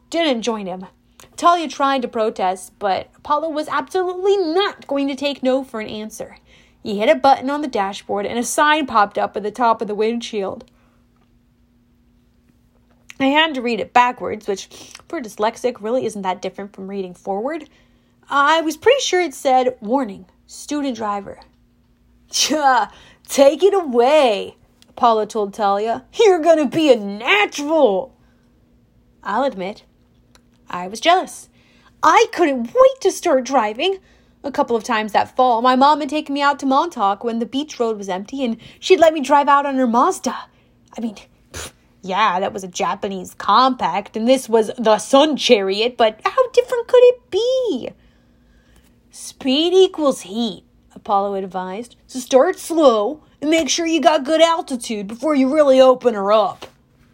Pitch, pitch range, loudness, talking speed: 255 Hz, 210-305 Hz, -17 LUFS, 160 wpm